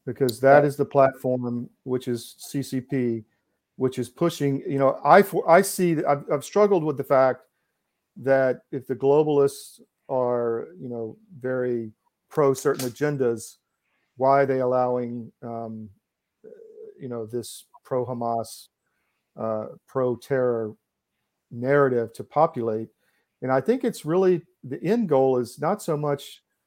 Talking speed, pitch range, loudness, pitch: 135 wpm, 120-145 Hz, -24 LUFS, 130 Hz